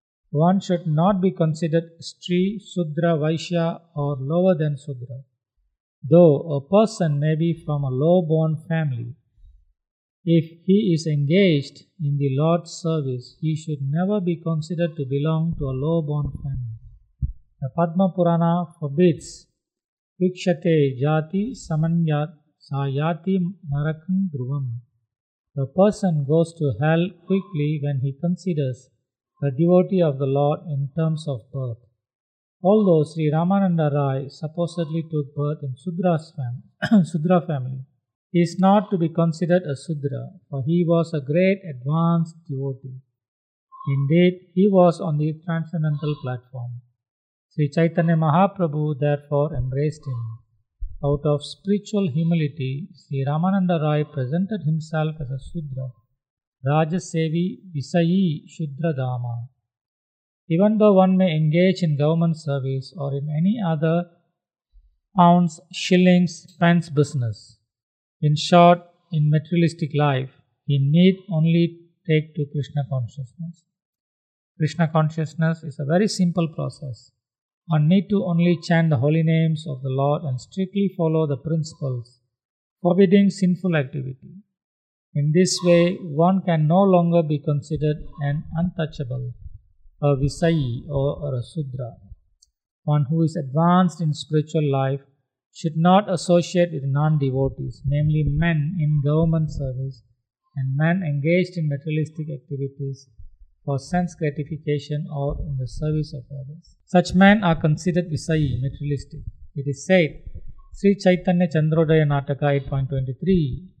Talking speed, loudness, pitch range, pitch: 125 wpm, -22 LUFS, 140-170 Hz, 155 Hz